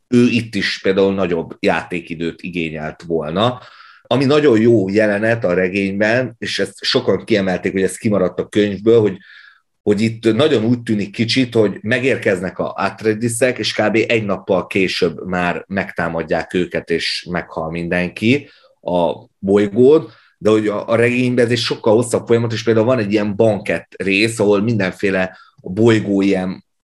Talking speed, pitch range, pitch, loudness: 150 wpm, 95-115 Hz, 105 Hz, -17 LUFS